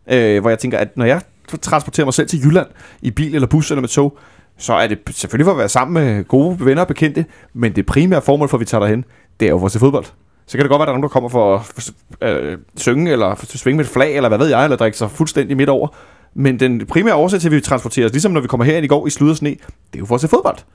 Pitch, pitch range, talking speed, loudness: 135 Hz, 120-150 Hz, 305 wpm, -15 LUFS